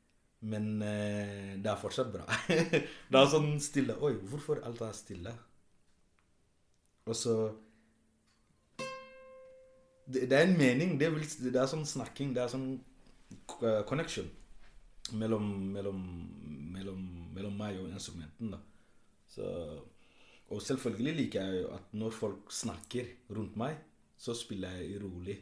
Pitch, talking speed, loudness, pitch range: 110 Hz, 130 wpm, -35 LUFS, 100-135 Hz